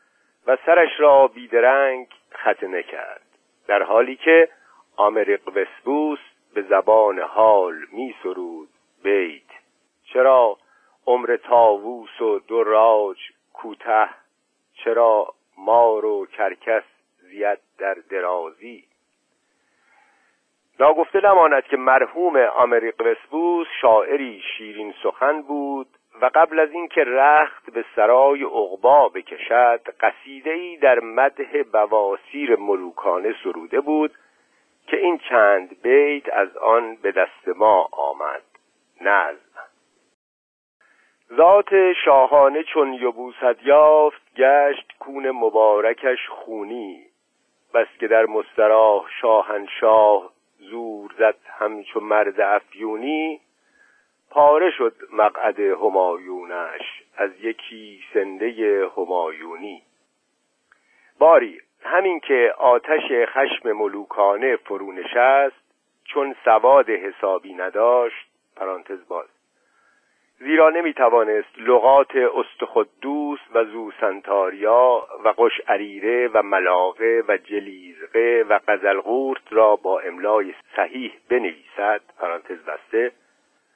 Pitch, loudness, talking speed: 145 Hz, -19 LUFS, 95 wpm